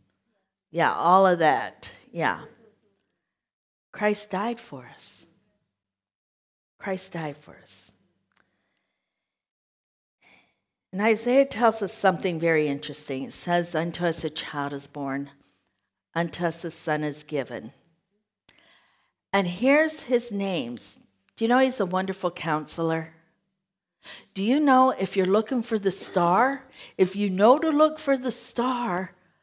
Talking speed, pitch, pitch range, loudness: 125 wpm, 190 Hz, 160-230 Hz, -25 LUFS